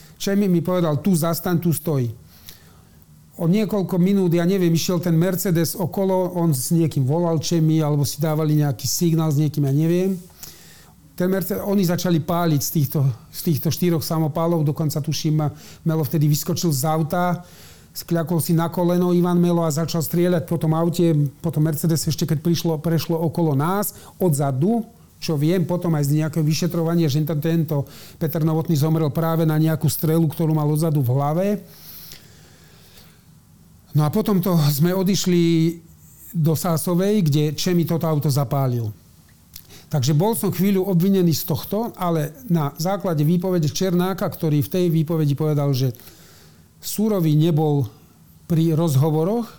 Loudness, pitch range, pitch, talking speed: -20 LUFS, 150-175 Hz, 165 Hz, 150 wpm